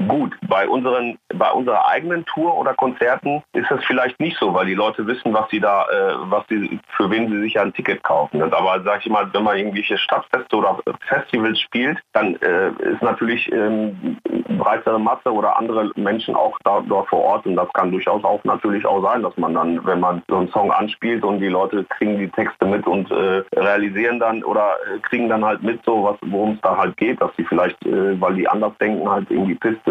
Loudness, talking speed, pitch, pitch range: -19 LUFS, 215 wpm, 110 Hz, 100-120 Hz